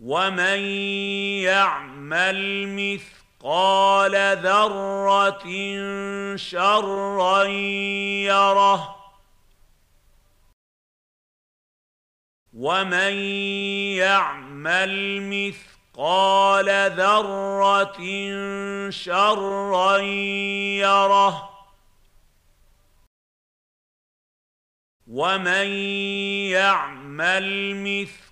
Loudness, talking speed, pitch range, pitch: -21 LUFS, 30 wpm, 185-200 Hz, 195 Hz